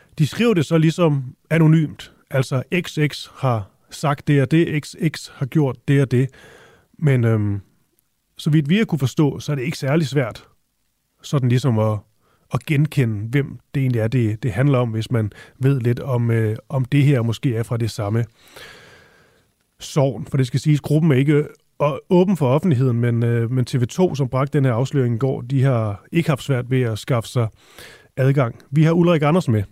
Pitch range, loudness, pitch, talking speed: 120-150 Hz, -20 LUFS, 135 Hz, 195 wpm